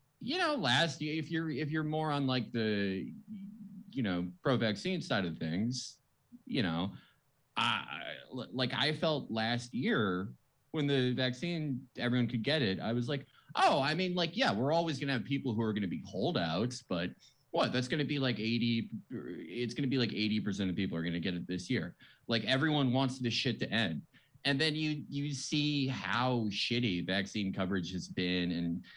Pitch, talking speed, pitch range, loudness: 130 Hz, 190 wpm, 110-150 Hz, -34 LUFS